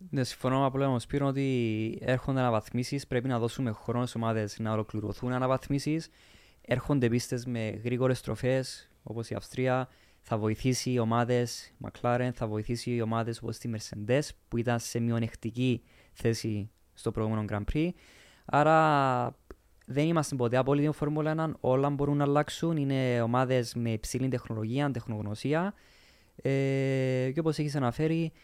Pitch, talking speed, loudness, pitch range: 125 Hz, 150 wpm, -30 LUFS, 115-135 Hz